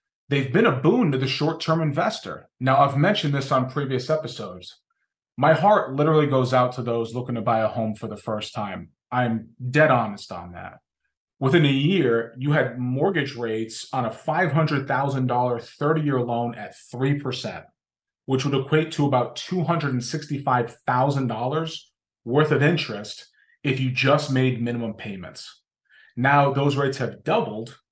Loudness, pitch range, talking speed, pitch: -23 LUFS, 120-150 Hz, 155 wpm, 130 Hz